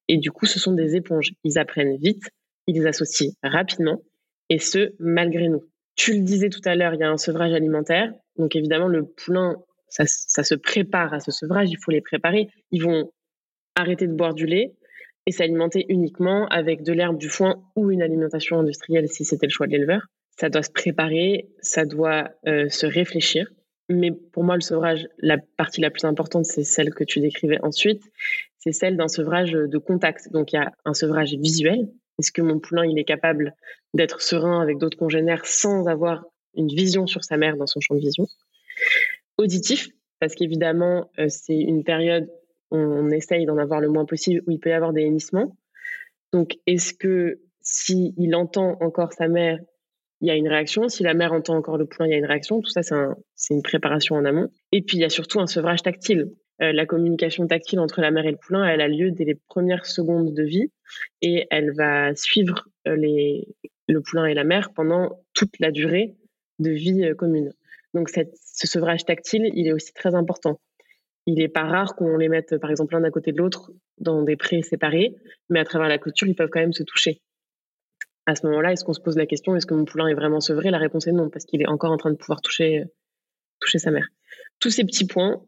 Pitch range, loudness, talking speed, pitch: 155-180 Hz, -22 LUFS, 215 wpm, 165 Hz